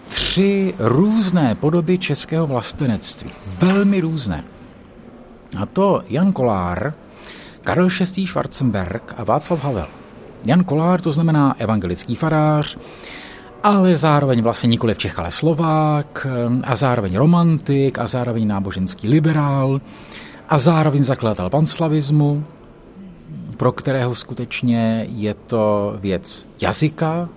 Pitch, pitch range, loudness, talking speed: 140 Hz, 115-165 Hz, -18 LUFS, 105 wpm